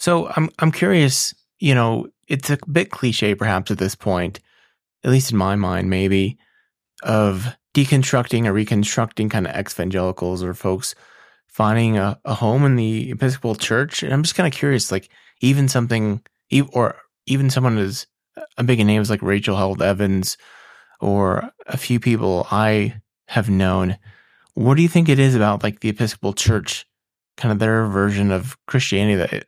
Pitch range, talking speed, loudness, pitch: 100-130 Hz, 175 wpm, -19 LUFS, 110 Hz